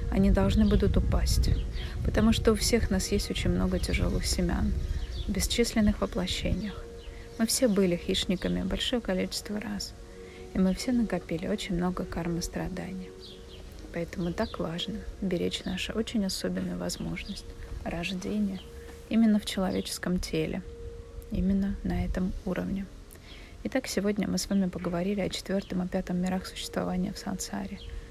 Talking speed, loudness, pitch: 135 wpm, -30 LUFS, 175 Hz